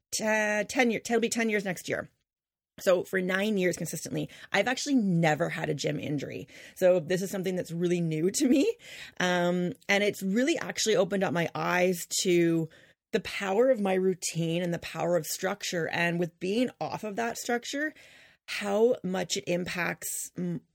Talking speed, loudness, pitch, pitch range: 180 wpm, -28 LUFS, 185 Hz, 175-215 Hz